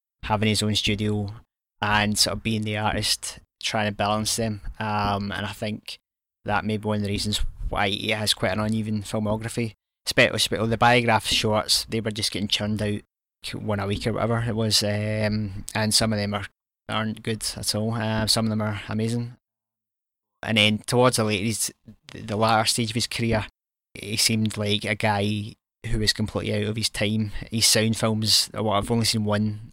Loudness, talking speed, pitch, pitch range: -24 LUFS, 195 wpm, 110 Hz, 105-110 Hz